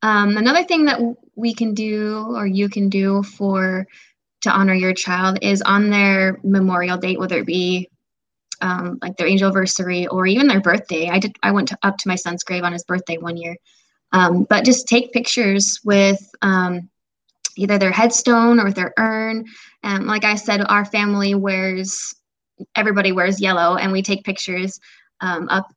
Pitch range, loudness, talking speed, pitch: 185-215 Hz, -18 LUFS, 185 wpm, 195 Hz